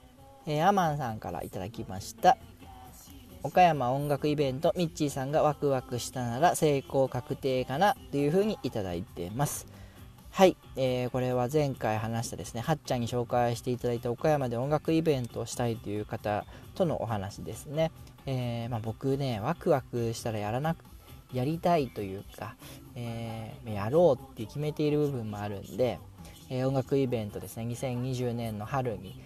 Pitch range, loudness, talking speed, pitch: 110-140 Hz, -30 LUFS, 340 characters per minute, 125 Hz